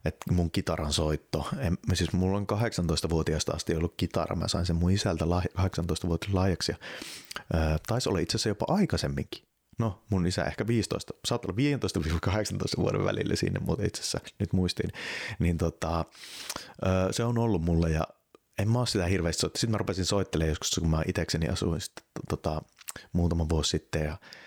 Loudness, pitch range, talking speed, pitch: -29 LUFS, 85-100 Hz, 170 wpm, 90 Hz